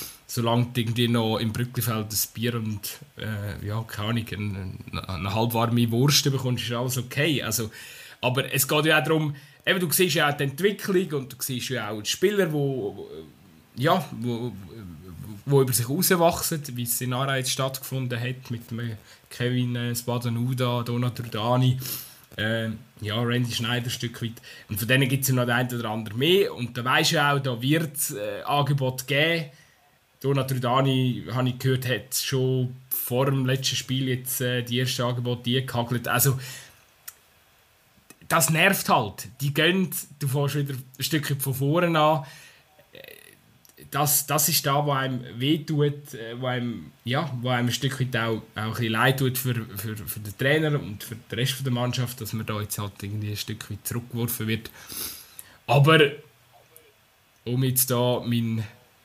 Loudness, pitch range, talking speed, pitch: -25 LUFS, 115-140 Hz, 170 wpm, 125 Hz